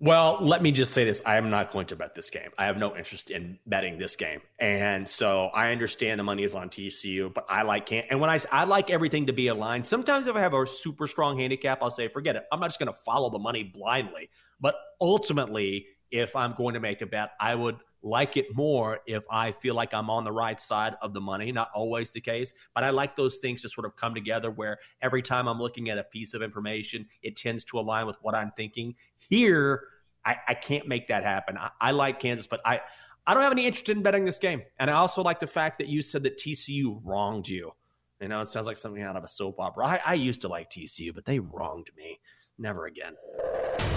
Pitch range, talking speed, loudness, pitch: 110-140 Hz, 245 wpm, -28 LUFS, 120 Hz